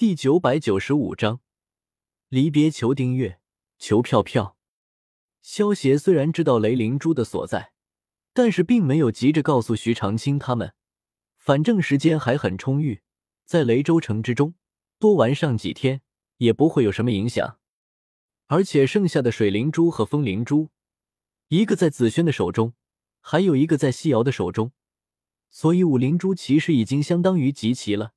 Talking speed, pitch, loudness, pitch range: 240 characters per minute, 140 Hz, -21 LUFS, 115-160 Hz